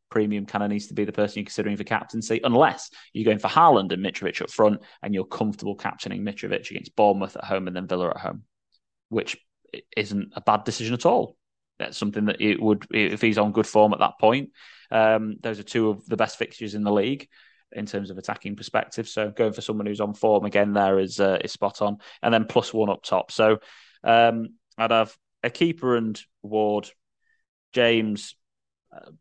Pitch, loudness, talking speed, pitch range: 105 Hz, -24 LUFS, 210 wpm, 105-110 Hz